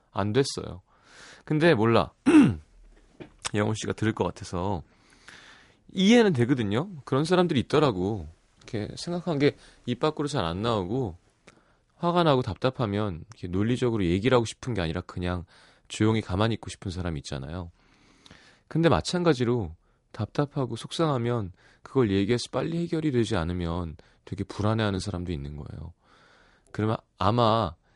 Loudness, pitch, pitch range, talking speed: -26 LUFS, 110 Hz, 95-135 Hz, 320 characters per minute